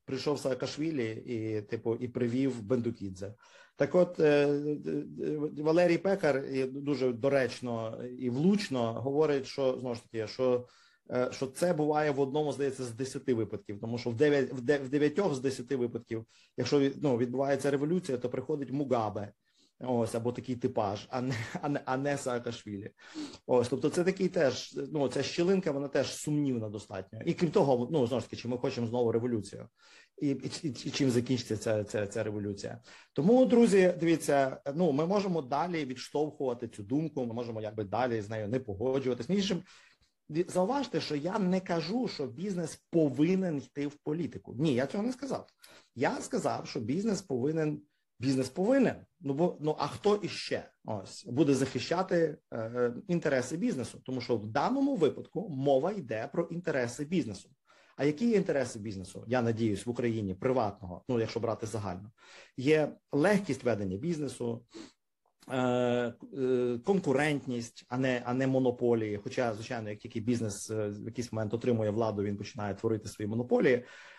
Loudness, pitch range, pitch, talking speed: -32 LUFS, 120-150 Hz, 130 Hz, 160 wpm